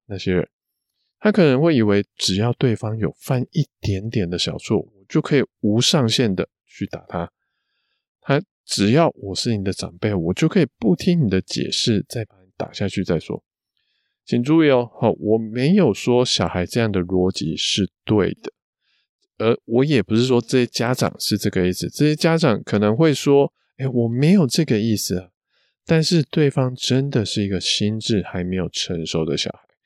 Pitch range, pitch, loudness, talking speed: 100-140 Hz, 115 Hz, -20 LUFS, 255 characters per minute